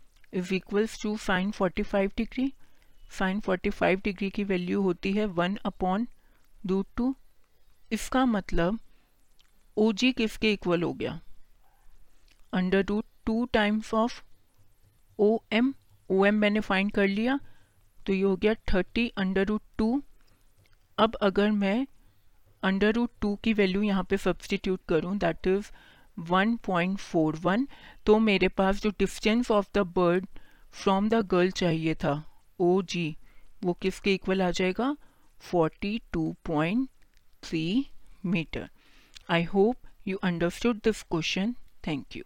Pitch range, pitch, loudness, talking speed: 180-215 Hz, 195 Hz, -28 LUFS, 120 wpm